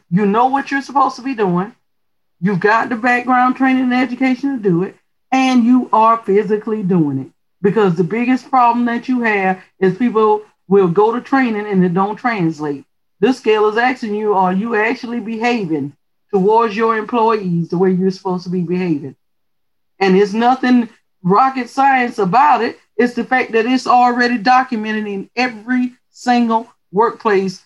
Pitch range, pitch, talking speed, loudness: 190-245 Hz, 225 Hz, 170 wpm, -15 LUFS